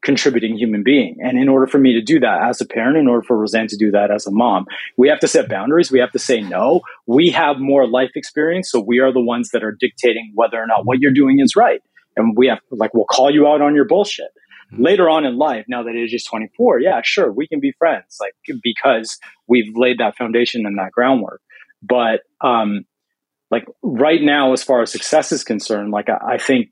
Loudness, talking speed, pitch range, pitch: -16 LUFS, 235 wpm, 115-140 Hz, 125 Hz